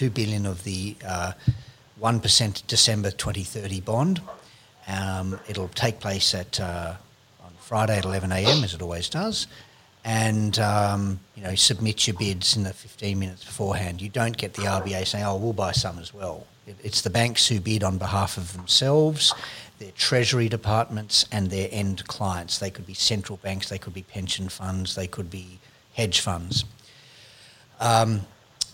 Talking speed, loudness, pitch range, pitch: 170 wpm, -24 LUFS, 95-115 Hz, 105 Hz